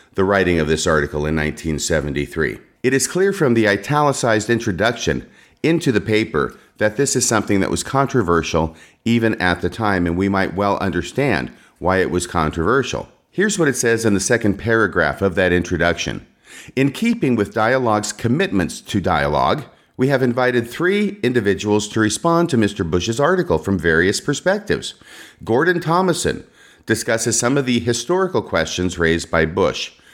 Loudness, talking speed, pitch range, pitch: -18 LUFS, 160 wpm, 90-130 Hz, 110 Hz